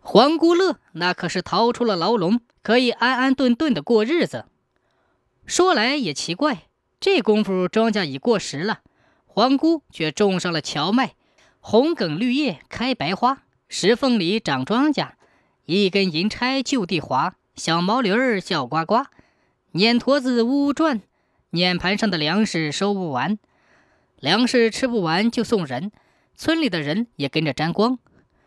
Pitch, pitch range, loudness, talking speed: 220 Hz, 180-255 Hz, -21 LUFS, 215 characters per minute